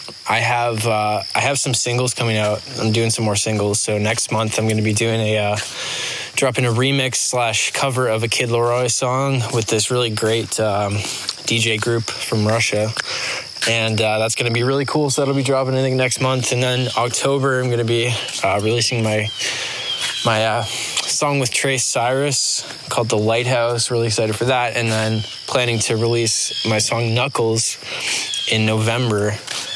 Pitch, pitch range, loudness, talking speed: 115 Hz, 110-125 Hz, -18 LUFS, 185 wpm